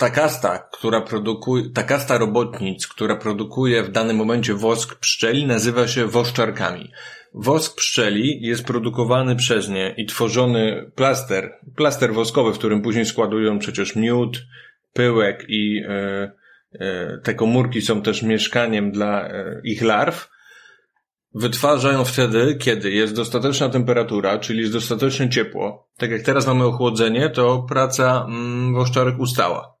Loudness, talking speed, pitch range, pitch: -20 LUFS, 125 wpm, 110-125 Hz, 120 Hz